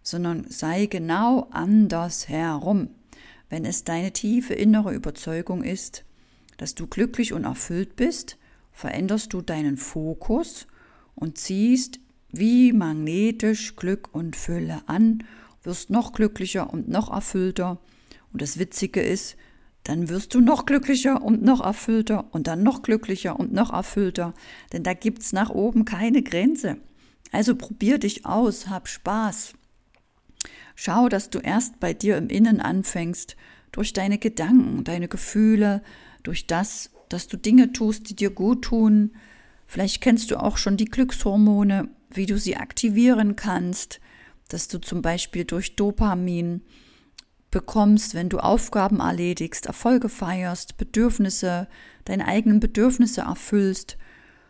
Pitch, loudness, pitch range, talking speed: 210 Hz, -23 LUFS, 180-230 Hz, 135 wpm